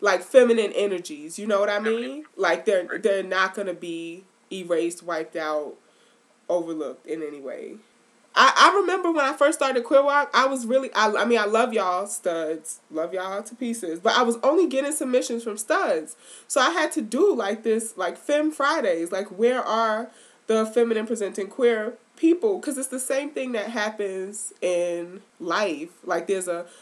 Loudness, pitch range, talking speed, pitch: -23 LUFS, 185-265 Hz, 185 wpm, 220 Hz